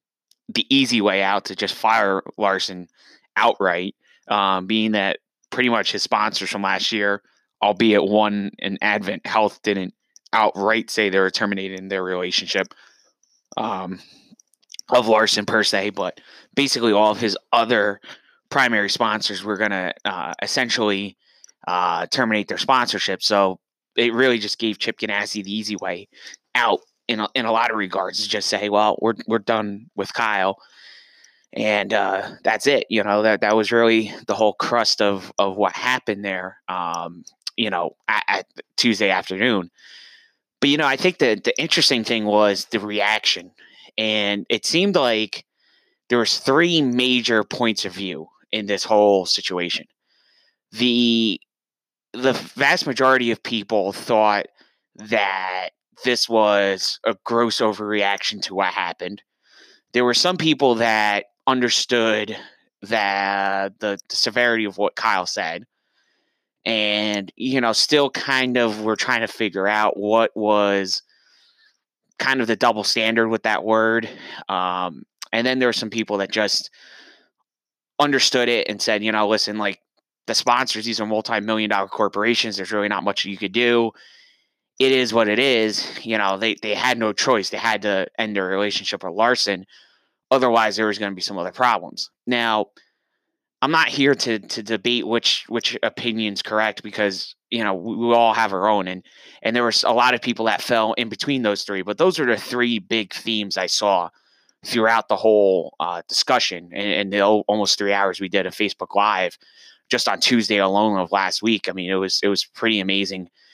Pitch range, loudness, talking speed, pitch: 100-115 Hz, -20 LUFS, 170 wpm, 110 Hz